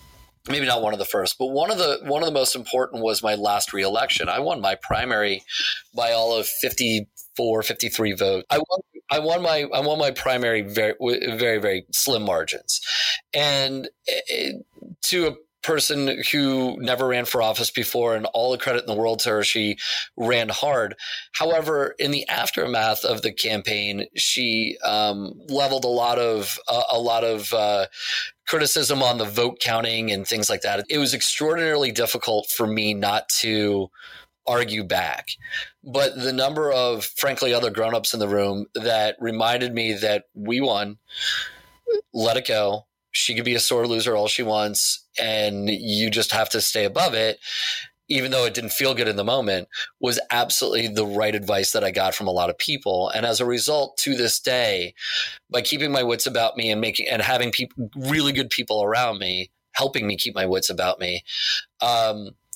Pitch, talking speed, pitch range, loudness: 115 Hz, 185 wpm, 105-130 Hz, -22 LUFS